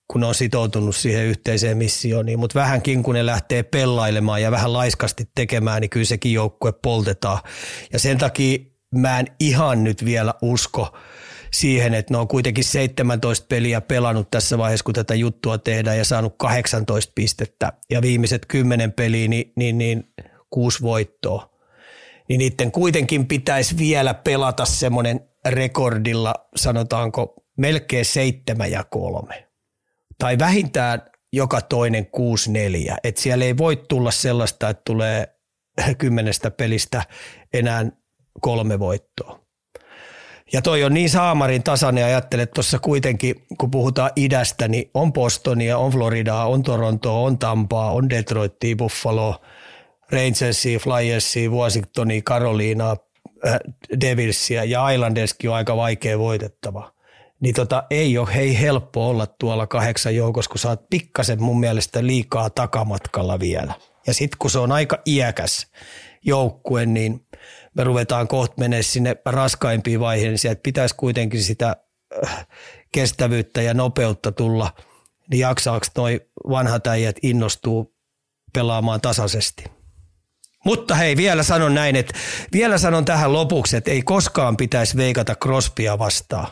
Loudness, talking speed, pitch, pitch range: -20 LUFS, 135 wpm, 120 Hz, 110-130 Hz